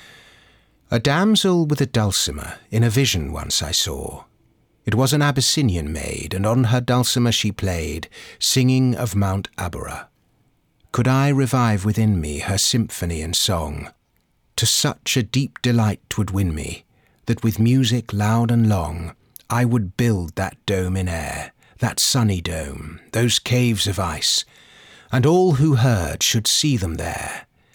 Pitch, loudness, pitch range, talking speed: 110 Hz, -20 LUFS, 90-125 Hz, 155 wpm